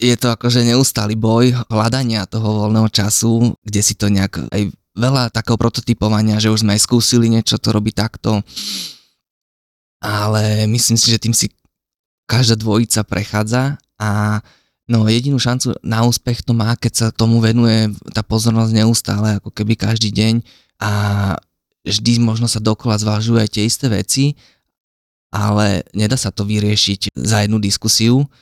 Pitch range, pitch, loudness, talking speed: 105-115 Hz, 110 Hz, -15 LUFS, 150 wpm